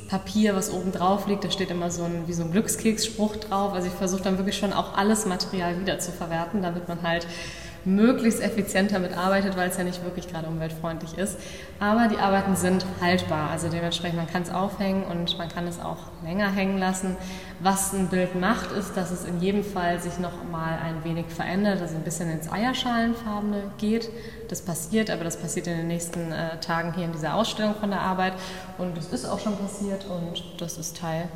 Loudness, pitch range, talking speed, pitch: -27 LUFS, 170-200 Hz, 210 wpm, 185 Hz